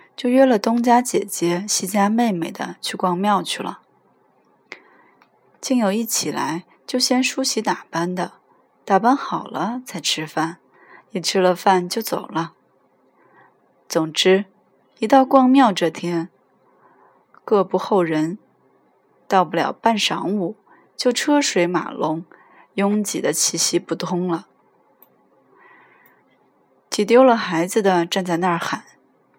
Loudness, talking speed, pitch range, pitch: -19 LUFS, 175 characters per minute, 175-240 Hz, 195 Hz